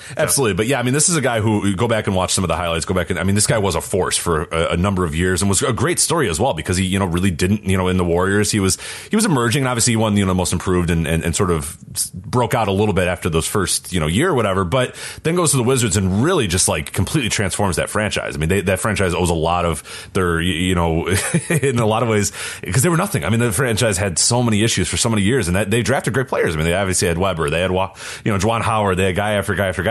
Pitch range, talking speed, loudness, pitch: 90-115 Hz, 315 wpm, -18 LUFS, 100 Hz